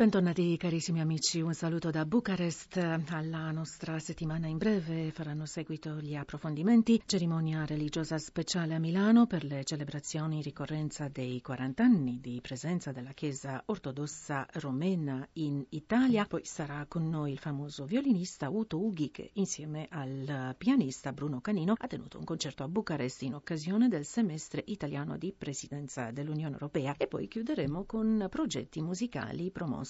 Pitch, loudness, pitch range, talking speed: 160 Hz, -33 LUFS, 145-180 Hz, 150 wpm